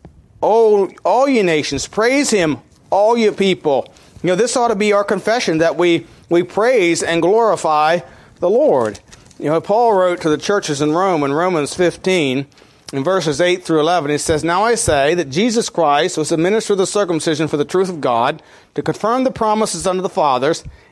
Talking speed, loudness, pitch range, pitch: 195 wpm, -16 LUFS, 155-215 Hz, 180 Hz